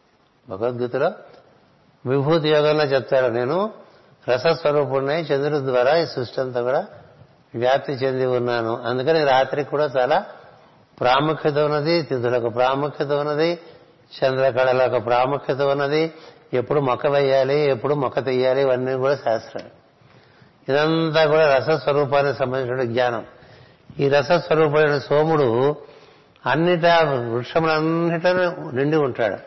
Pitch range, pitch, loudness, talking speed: 125-155 Hz, 140 Hz, -20 LUFS, 100 wpm